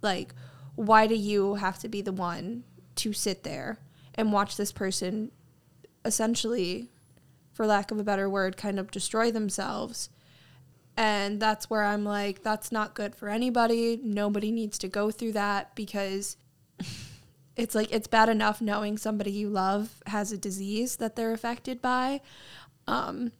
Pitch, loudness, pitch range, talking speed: 205 Hz, -29 LUFS, 195-220 Hz, 155 wpm